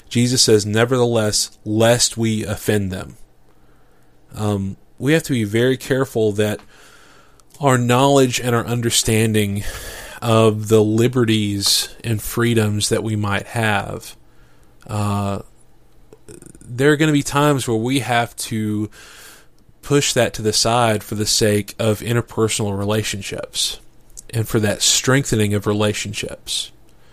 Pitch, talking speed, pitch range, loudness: 110 Hz, 125 wpm, 105-120 Hz, -18 LUFS